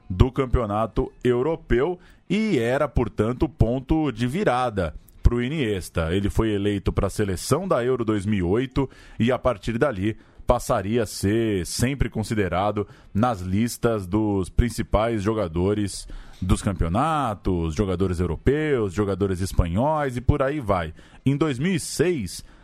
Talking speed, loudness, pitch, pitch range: 125 wpm, -24 LUFS, 110 Hz, 100-125 Hz